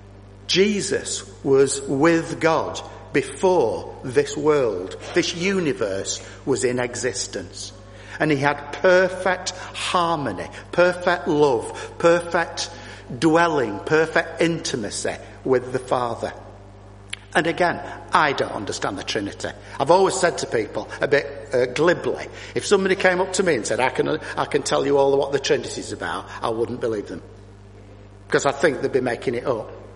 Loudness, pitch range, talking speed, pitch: -22 LUFS, 110-180 Hz, 150 wpm, 155 Hz